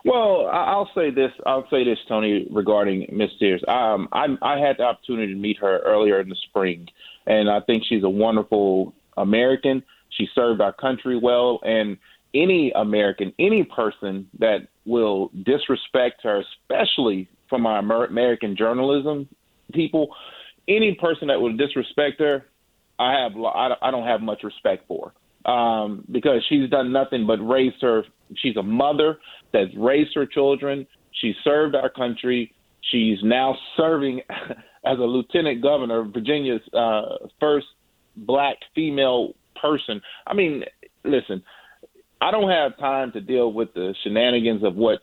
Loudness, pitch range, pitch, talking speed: -22 LUFS, 110-140 Hz, 125 Hz, 150 wpm